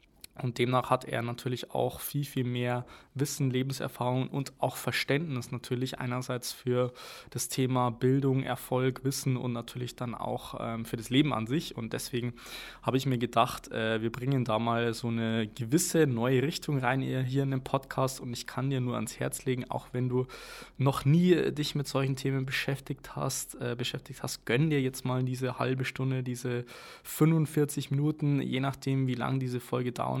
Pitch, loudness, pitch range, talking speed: 130 Hz, -31 LUFS, 125-135 Hz, 175 wpm